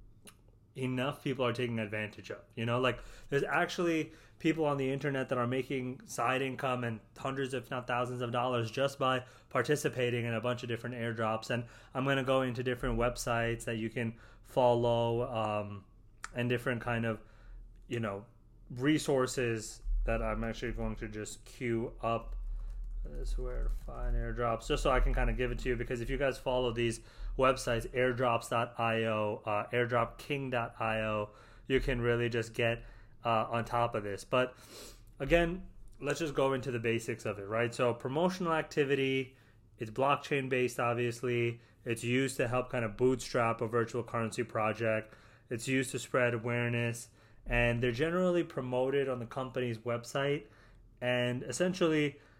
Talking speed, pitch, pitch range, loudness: 165 wpm, 120 Hz, 115-130 Hz, -34 LUFS